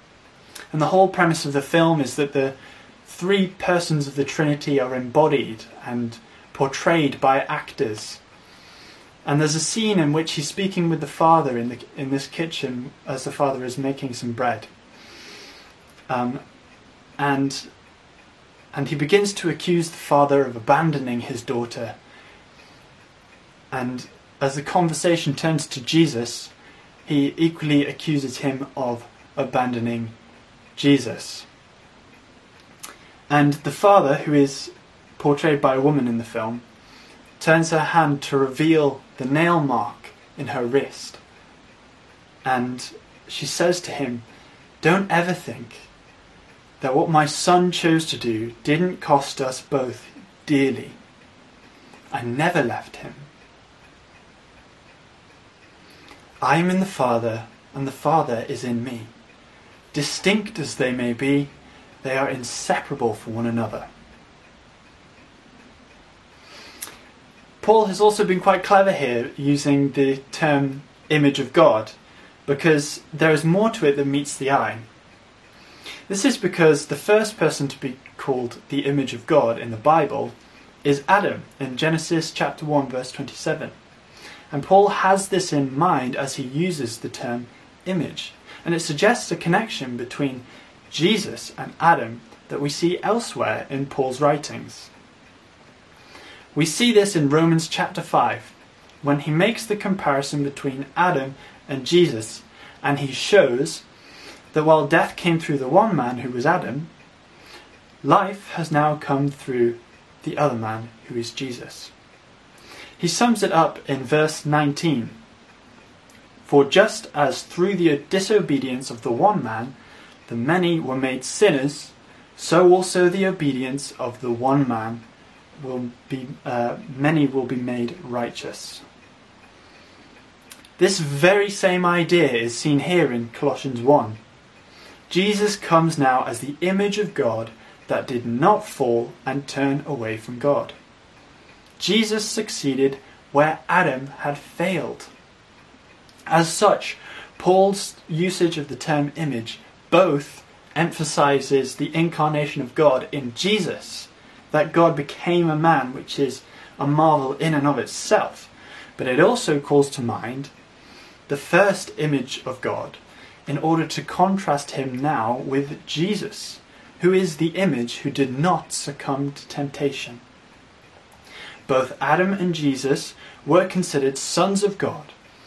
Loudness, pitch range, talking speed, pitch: -21 LUFS, 130-165 Hz, 135 wpm, 145 Hz